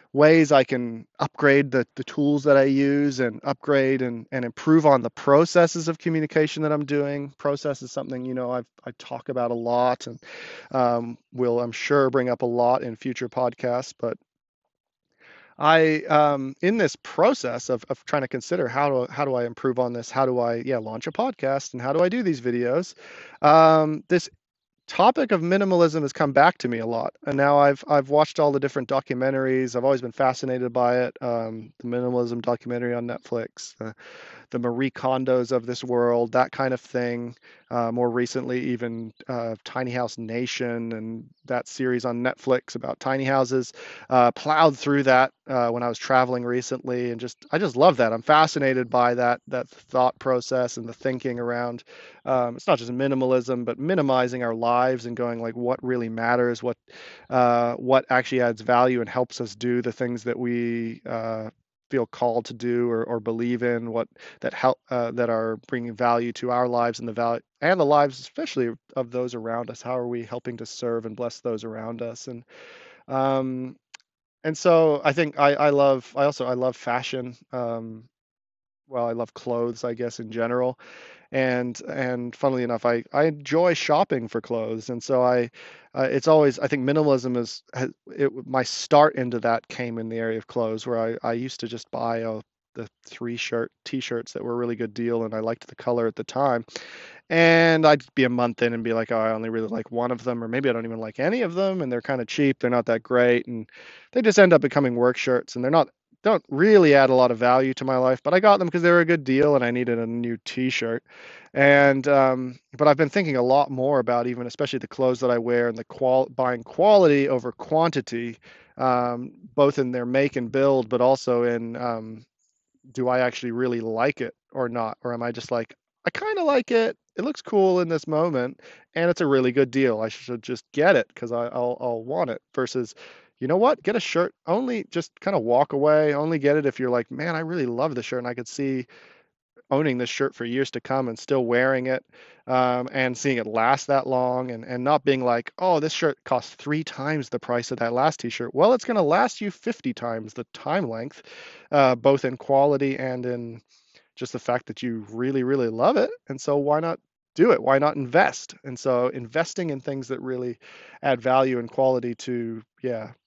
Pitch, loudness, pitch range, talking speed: 125 Hz, -23 LUFS, 120-140 Hz, 210 wpm